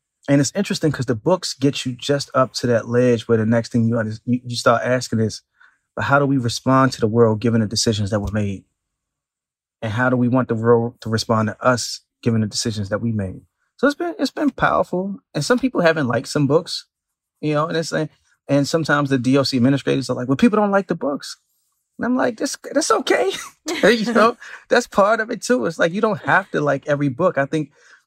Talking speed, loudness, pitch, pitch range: 230 wpm, -19 LUFS, 135 Hz, 115-165 Hz